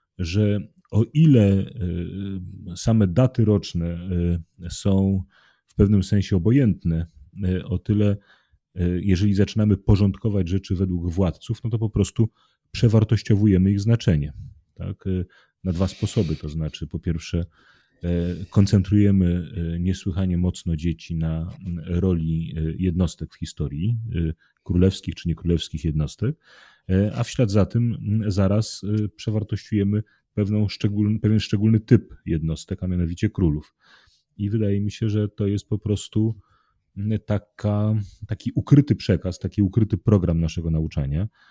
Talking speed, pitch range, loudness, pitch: 120 wpm, 85-105 Hz, -23 LUFS, 100 Hz